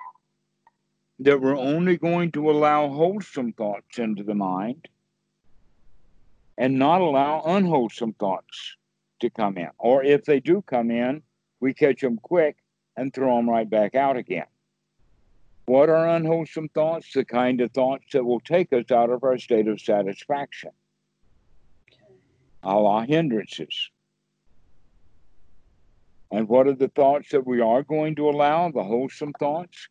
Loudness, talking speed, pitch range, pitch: -23 LUFS, 140 wpm, 115-155 Hz, 130 Hz